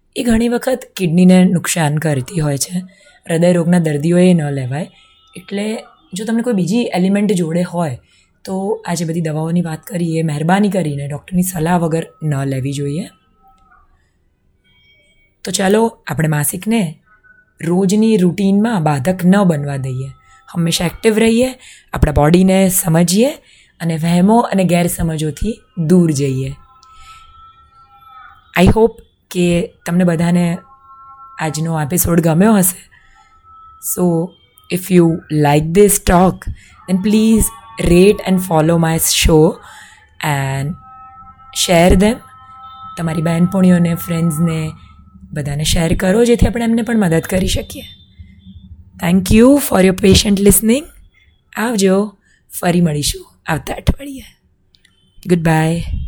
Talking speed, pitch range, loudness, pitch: 115 wpm, 160-220 Hz, -14 LUFS, 180 Hz